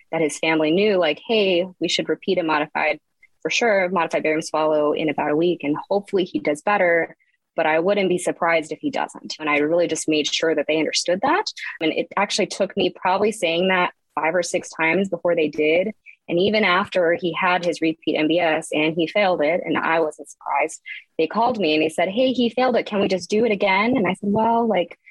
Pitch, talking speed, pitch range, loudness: 175 Hz, 225 wpm, 160-200 Hz, -21 LUFS